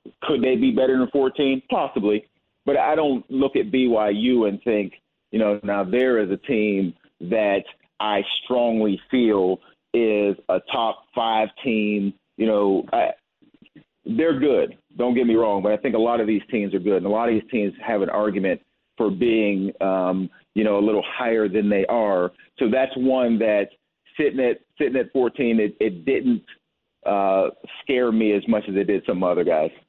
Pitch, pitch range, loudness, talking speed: 110 Hz, 100-125 Hz, -22 LUFS, 185 wpm